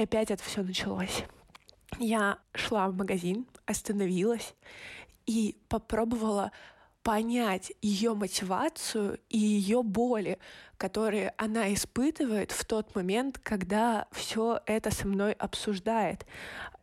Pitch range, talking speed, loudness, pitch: 200-230 Hz, 105 wpm, -31 LUFS, 215 Hz